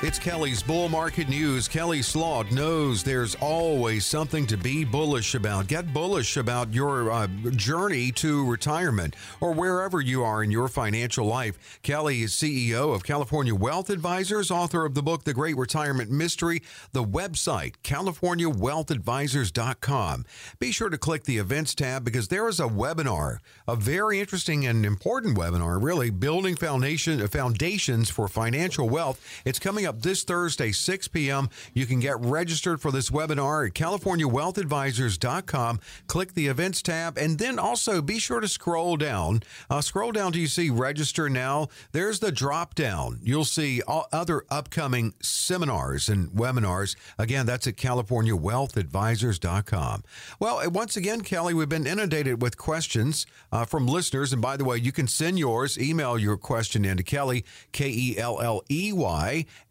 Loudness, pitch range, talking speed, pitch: -26 LUFS, 120-165 Hz, 155 wpm, 140 Hz